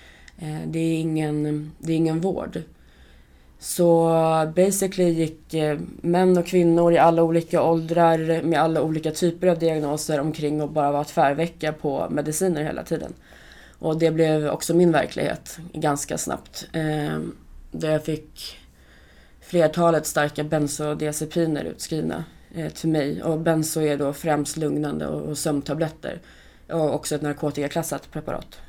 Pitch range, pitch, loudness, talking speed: 145-165 Hz, 155 Hz, -23 LUFS, 130 wpm